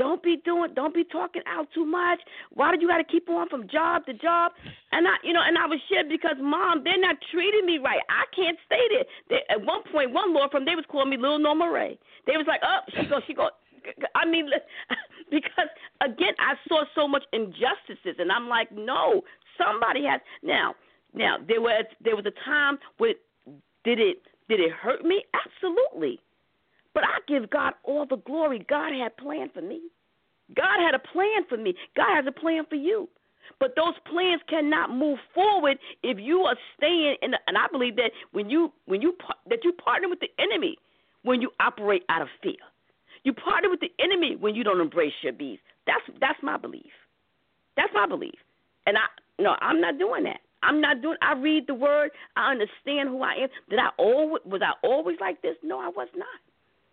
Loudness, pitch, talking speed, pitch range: -25 LUFS, 315 Hz, 210 wpm, 275-350 Hz